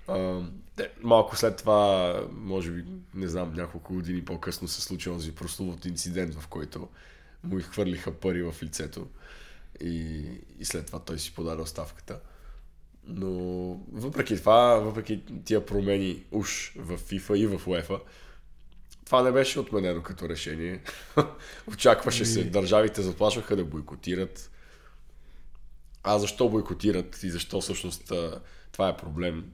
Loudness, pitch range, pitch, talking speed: -28 LUFS, 85-105 Hz, 90 Hz, 130 wpm